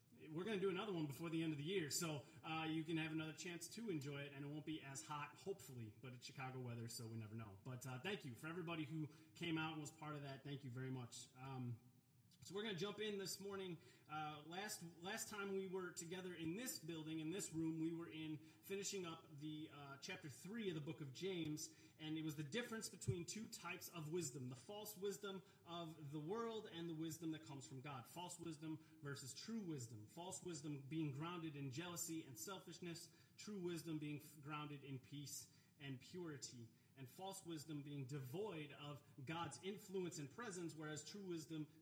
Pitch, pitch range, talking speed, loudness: 160 Hz, 145-180 Hz, 210 wpm, -51 LUFS